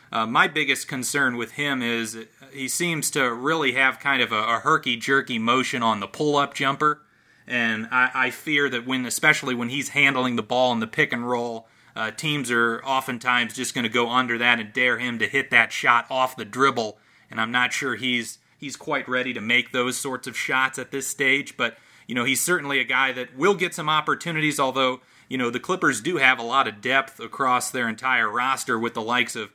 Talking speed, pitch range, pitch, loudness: 220 wpm, 120-135 Hz, 130 Hz, -22 LUFS